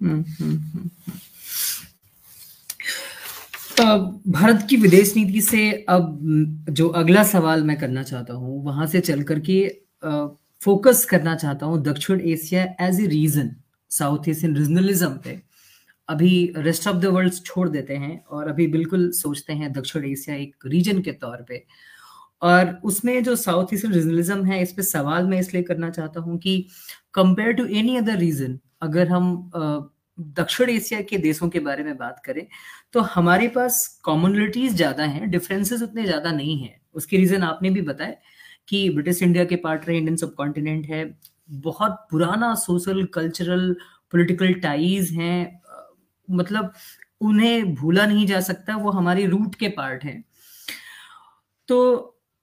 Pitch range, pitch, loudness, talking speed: 155-195 Hz, 175 Hz, -21 LUFS, 145 wpm